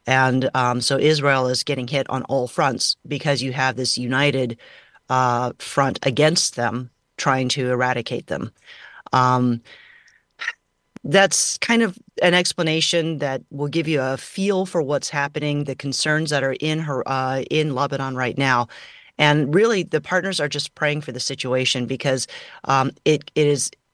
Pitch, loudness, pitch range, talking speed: 140 Hz, -21 LUFS, 130-155 Hz, 160 wpm